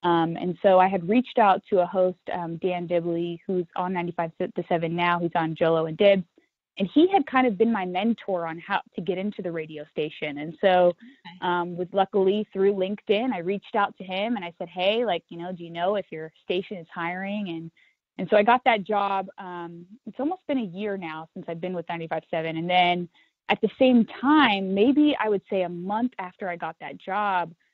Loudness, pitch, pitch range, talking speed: -25 LUFS, 185 Hz, 170-205 Hz, 225 wpm